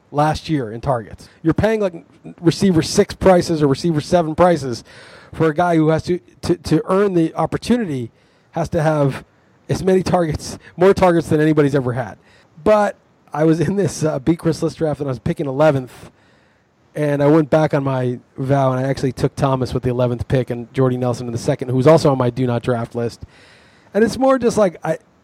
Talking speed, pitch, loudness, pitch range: 210 wpm, 155 Hz, -18 LUFS, 130-170 Hz